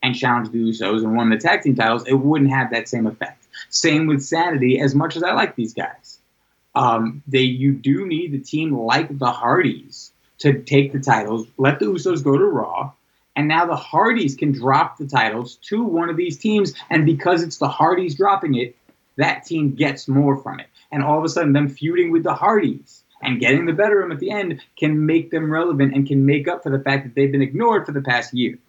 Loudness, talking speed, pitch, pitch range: -19 LUFS, 230 wpm, 140 Hz, 130-160 Hz